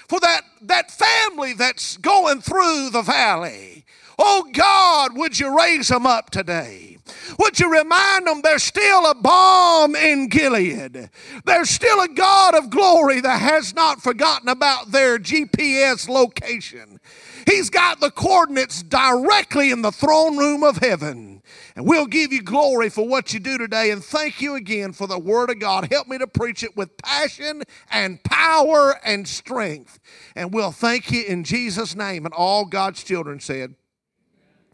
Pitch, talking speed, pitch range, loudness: 275 Hz, 160 wpm, 225-320 Hz, -17 LUFS